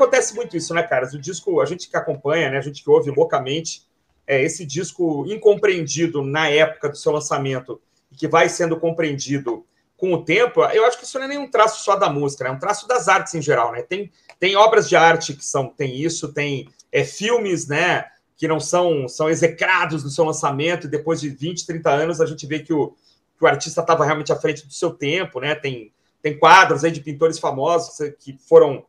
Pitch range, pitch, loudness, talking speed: 150-180 Hz, 165 Hz, -19 LUFS, 220 wpm